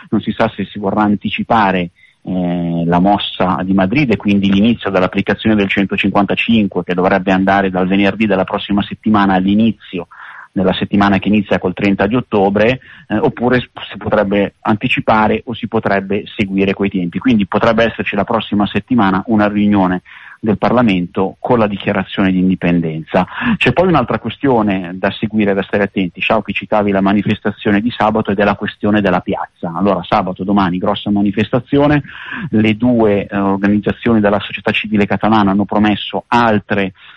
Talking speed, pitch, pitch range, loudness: 160 wpm, 100 Hz, 95-110 Hz, -14 LUFS